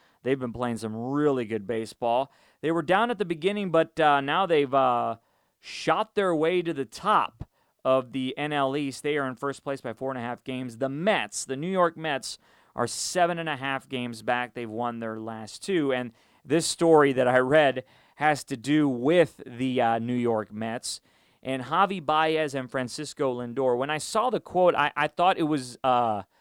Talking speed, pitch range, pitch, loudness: 200 wpm, 125-155 Hz, 135 Hz, -26 LUFS